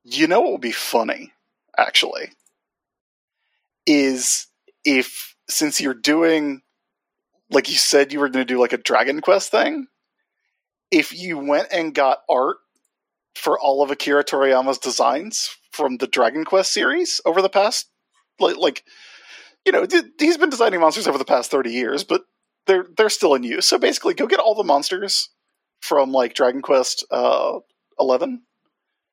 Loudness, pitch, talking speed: -19 LUFS, 195 Hz, 155 wpm